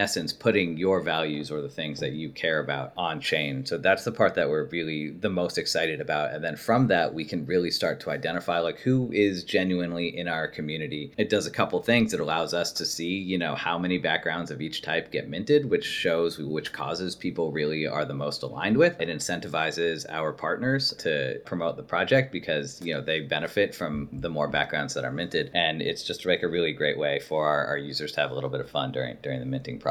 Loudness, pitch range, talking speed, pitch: -27 LUFS, 75-95 Hz, 235 wpm, 85 Hz